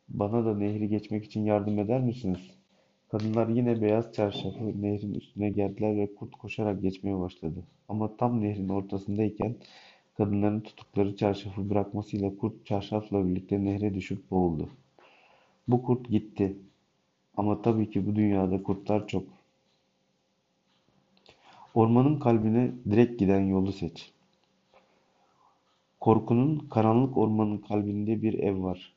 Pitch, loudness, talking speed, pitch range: 105 Hz, -29 LUFS, 120 wpm, 100-110 Hz